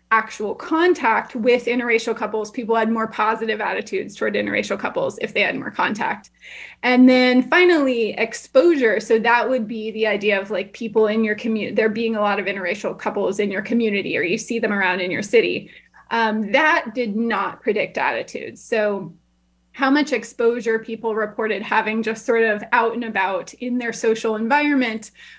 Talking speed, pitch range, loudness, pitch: 175 wpm, 215-245 Hz, -20 LUFS, 225 Hz